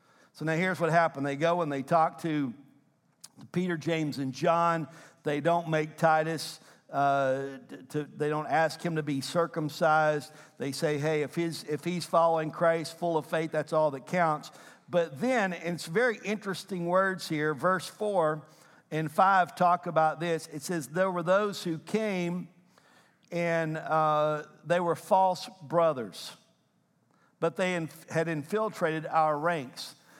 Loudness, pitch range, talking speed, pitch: -29 LUFS, 155-175 Hz, 155 wpm, 165 Hz